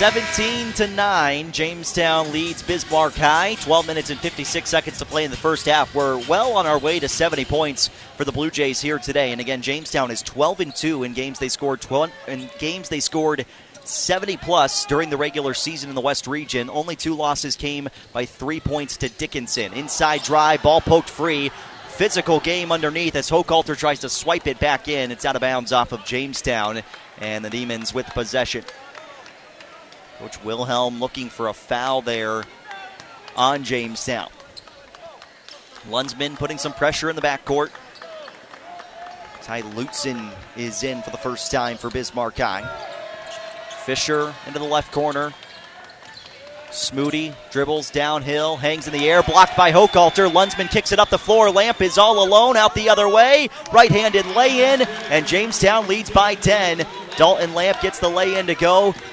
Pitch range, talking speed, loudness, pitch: 135-180 Hz, 165 wpm, -19 LUFS, 150 Hz